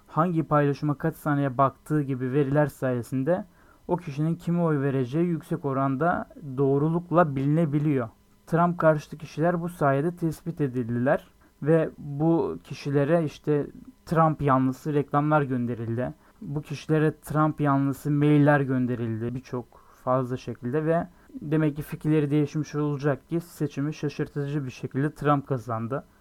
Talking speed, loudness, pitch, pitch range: 125 wpm, -26 LUFS, 145 Hz, 135-155 Hz